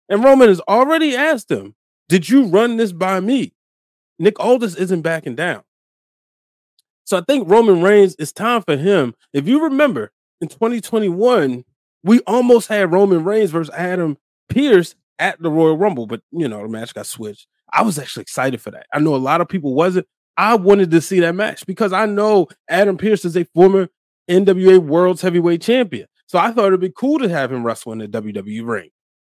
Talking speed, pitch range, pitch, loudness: 195 wpm, 160-220 Hz, 185 Hz, -16 LUFS